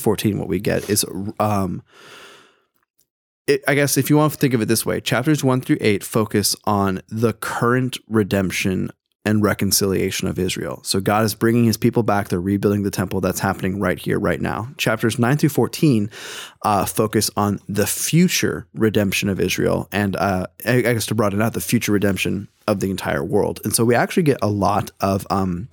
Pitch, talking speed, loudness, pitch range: 110 Hz, 195 wpm, -20 LUFS, 100-125 Hz